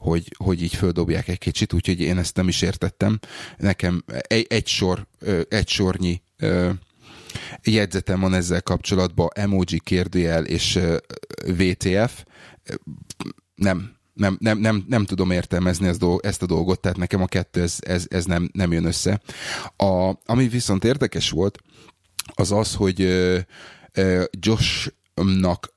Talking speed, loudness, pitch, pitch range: 130 wpm, -22 LUFS, 95 Hz, 90-100 Hz